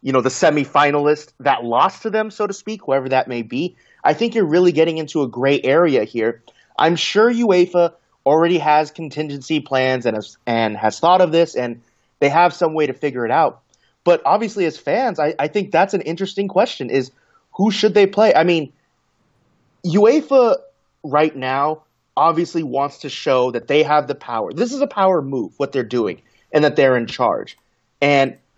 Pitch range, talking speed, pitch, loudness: 135-185 Hz, 195 wpm, 155 Hz, -17 LUFS